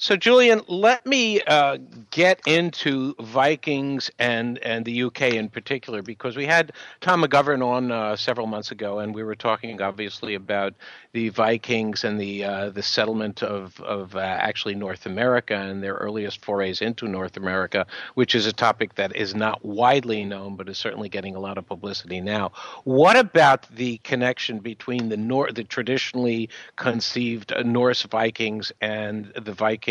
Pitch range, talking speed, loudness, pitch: 105-125 Hz, 165 wpm, -23 LUFS, 115 Hz